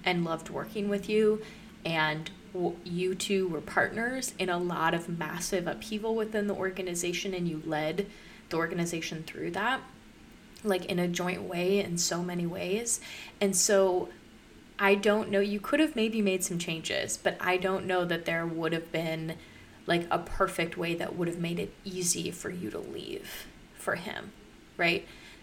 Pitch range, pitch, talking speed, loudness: 170-200 Hz, 185 Hz, 170 wpm, -30 LUFS